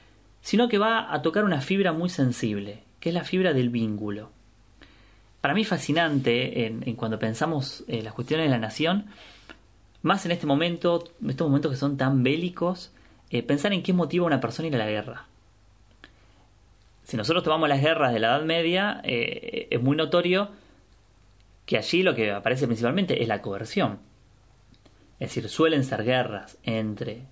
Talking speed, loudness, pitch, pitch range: 175 wpm, -25 LUFS, 125 Hz, 105-170 Hz